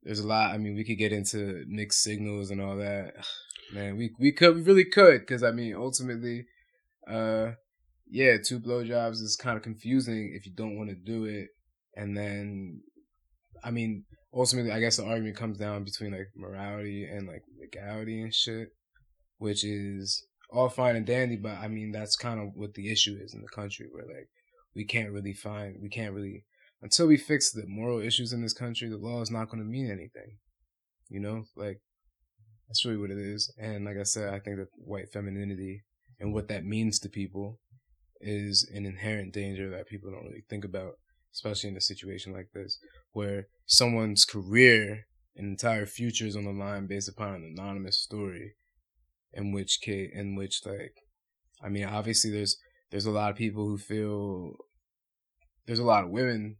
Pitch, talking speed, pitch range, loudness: 105 Hz, 190 wpm, 100-115 Hz, -28 LUFS